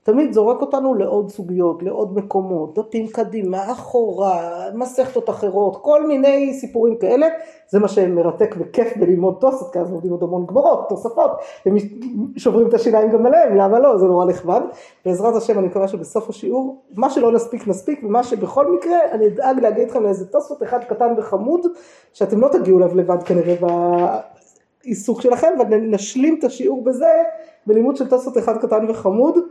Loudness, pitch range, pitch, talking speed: -17 LUFS, 195-260 Hz, 225 Hz, 160 wpm